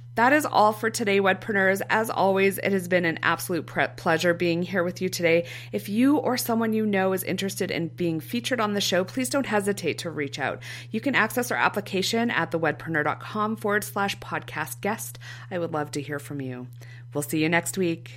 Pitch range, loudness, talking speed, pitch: 150-210 Hz, -25 LUFS, 210 wpm, 180 Hz